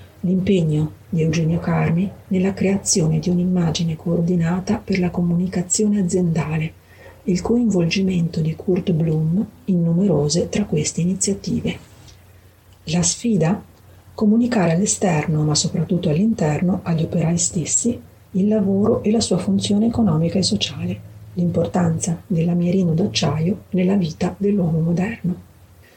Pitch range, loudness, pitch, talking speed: 160-195 Hz, -19 LUFS, 175 Hz, 115 wpm